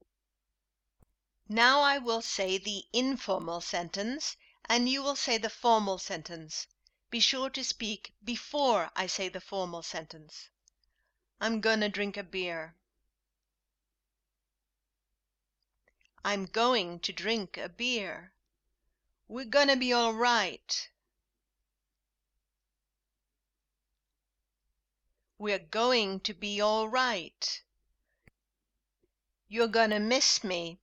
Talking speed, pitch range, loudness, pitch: 95 wpm, 170-235 Hz, -30 LUFS, 205 Hz